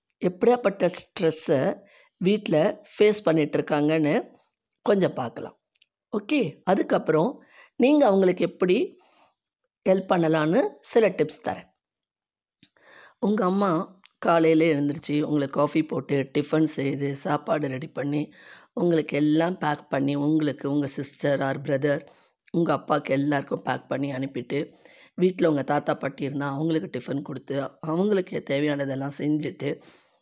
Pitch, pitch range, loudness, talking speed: 155 Hz, 145-180 Hz, -25 LUFS, 110 wpm